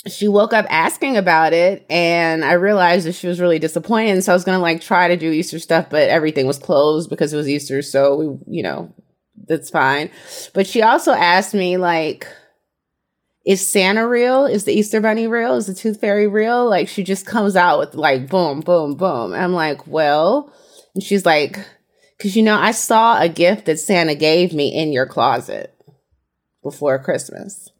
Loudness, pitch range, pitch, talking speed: -16 LUFS, 155-205 Hz, 180 Hz, 195 wpm